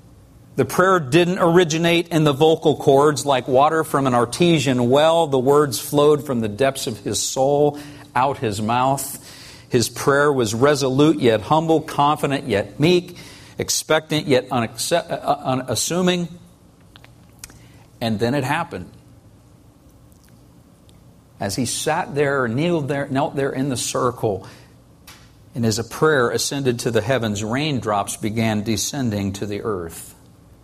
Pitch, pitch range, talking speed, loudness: 140 Hz, 120-155 Hz, 130 wpm, -19 LUFS